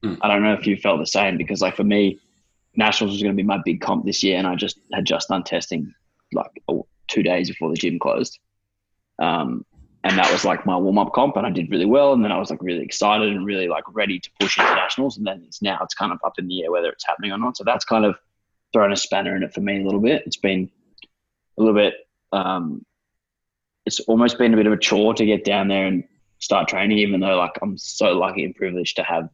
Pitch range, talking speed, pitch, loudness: 95-110 Hz, 260 wpm, 105 Hz, -20 LUFS